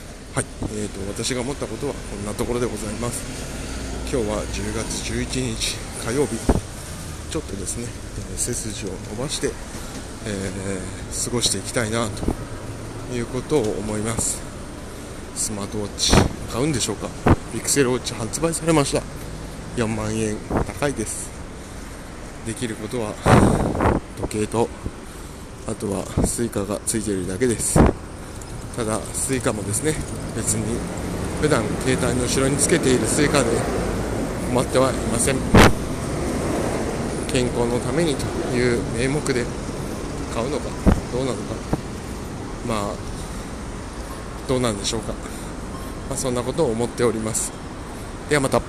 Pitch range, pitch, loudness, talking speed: 95-120 Hz, 110 Hz, -23 LUFS, 270 characters per minute